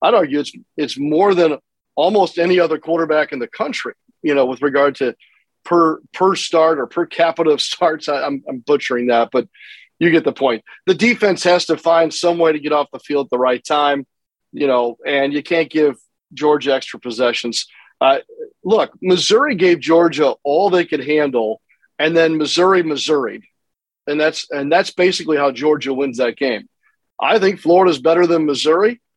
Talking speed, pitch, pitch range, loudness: 185 wpm, 155 Hz, 140-175 Hz, -16 LUFS